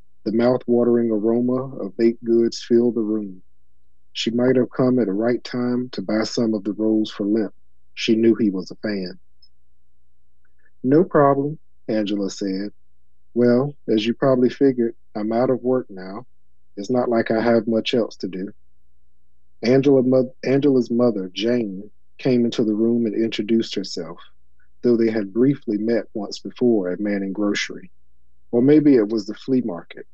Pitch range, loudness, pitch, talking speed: 95-125 Hz, -20 LUFS, 115 Hz, 165 wpm